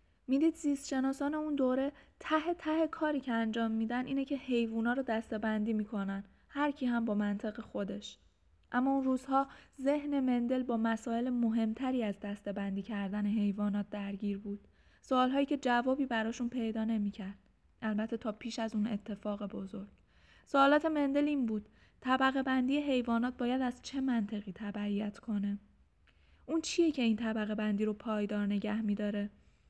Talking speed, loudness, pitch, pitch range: 150 wpm, -34 LUFS, 230 Hz, 210-265 Hz